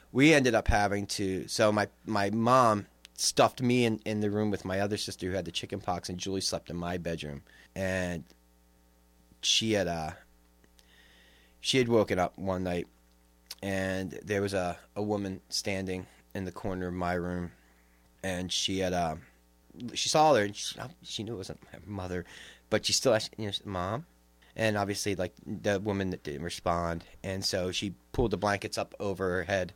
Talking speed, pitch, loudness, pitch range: 185 wpm, 90 Hz, -30 LUFS, 70-100 Hz